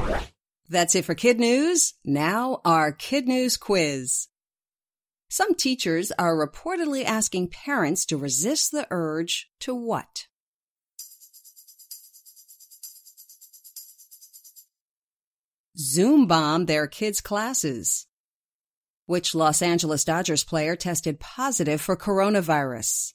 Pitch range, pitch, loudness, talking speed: 160-250 Hz, 180 Hz, -23 LUFS, 95 wpm